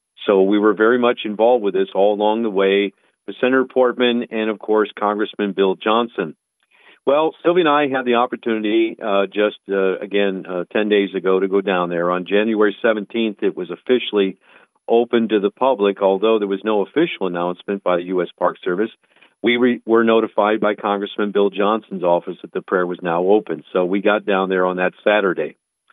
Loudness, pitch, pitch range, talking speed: -18 LUFS, 105 Hz, 95-115 Hz, 195 wpm